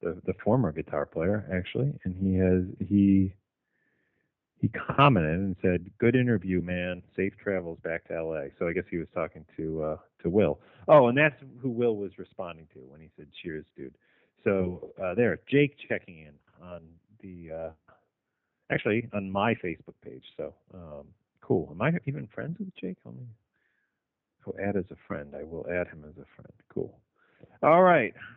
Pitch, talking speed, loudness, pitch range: 95 Hz, 180 wpm, -28 LUFS, 85-110 Hz